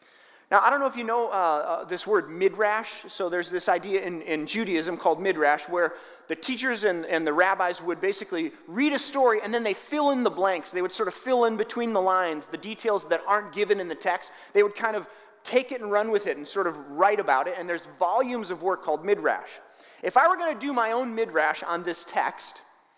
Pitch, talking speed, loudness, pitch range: 195 Hz, 240 wpm, -26 LUFS, 175-225 Hz